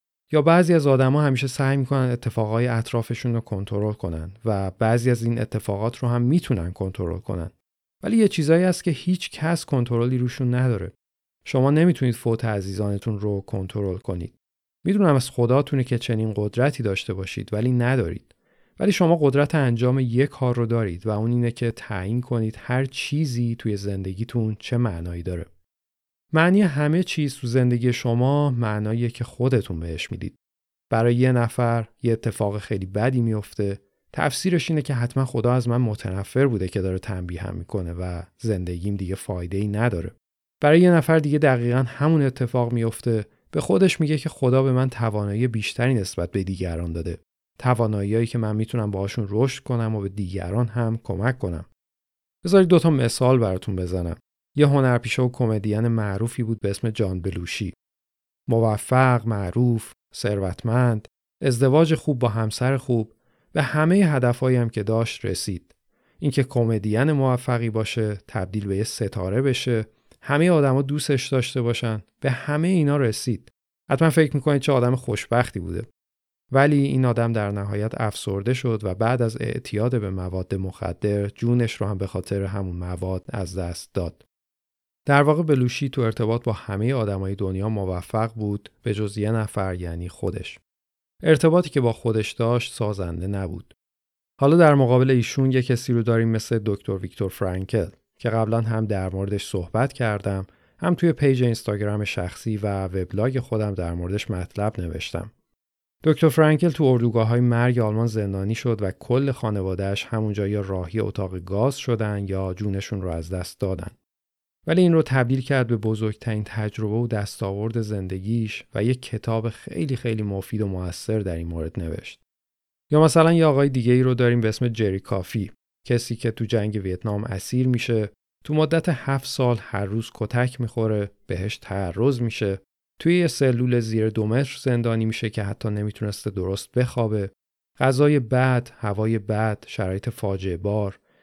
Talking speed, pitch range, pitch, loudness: 160 wpm, 100-130 Hz, 115 Hz, -23 LUFS